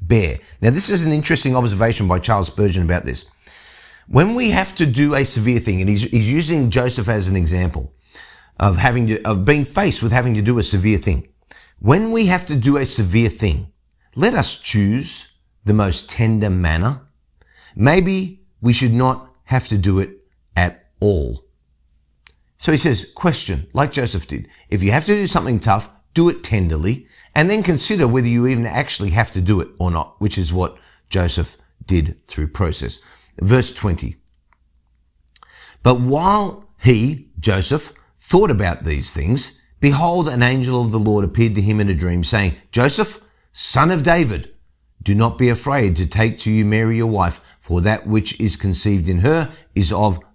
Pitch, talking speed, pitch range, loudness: 110 Hz, 180 wpm, 90-130 Hz, -17 LUFS